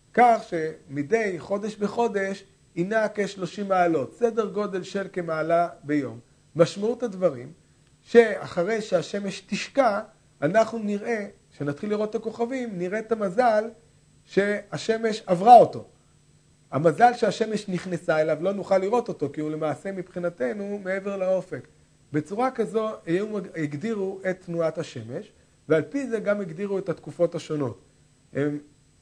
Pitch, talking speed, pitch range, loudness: 190 Hz, 120 wpm, 160-215 Hz, -25 LUFS